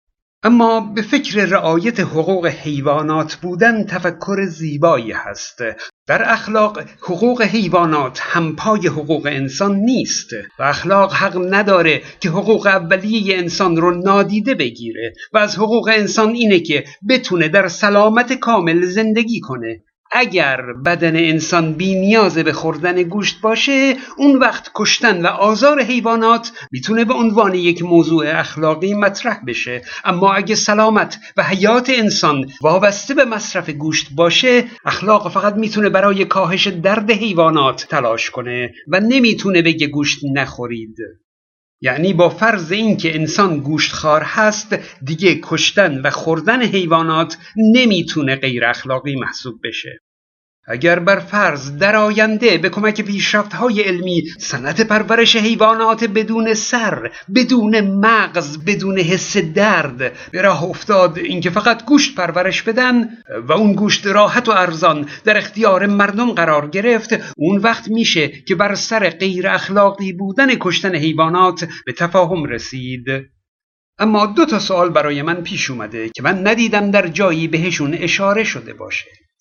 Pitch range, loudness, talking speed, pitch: 160-215 Hz, -15 LUFS, 135 wpm, 190 Hz